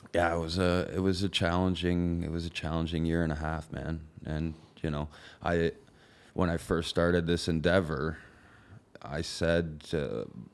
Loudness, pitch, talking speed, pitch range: -31 LUFS, 85 Hz, 170 wpm, 80-90 Hz